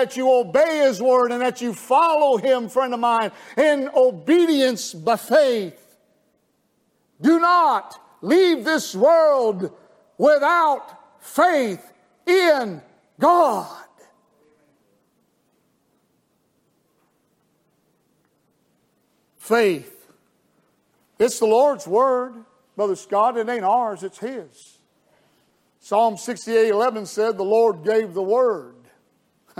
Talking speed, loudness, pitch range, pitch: 95 wpm, -19 LUFS, 225-300 Hz, 250 Hz